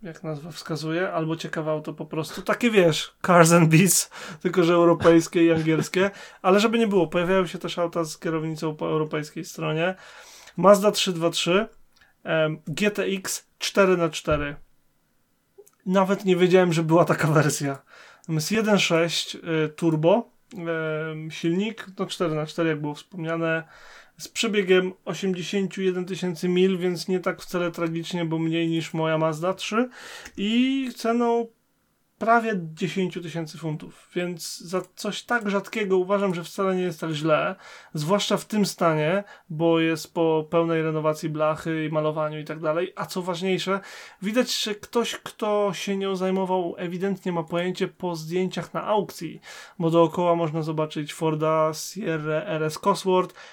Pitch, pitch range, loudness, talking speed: 175 Hz, 160-195 Hz, -24 LUFS, 140 wpm